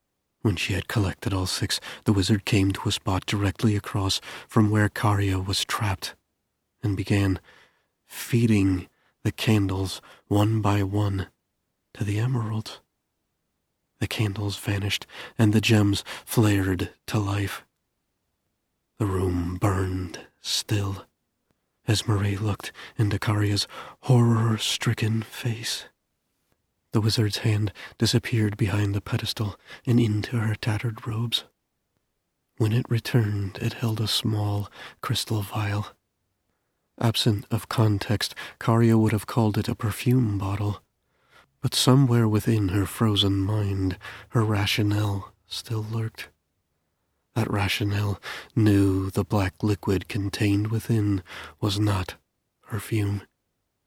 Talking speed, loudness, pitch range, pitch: 115 wpm, -25 LUFS, 100-110 Hz, 105 Hz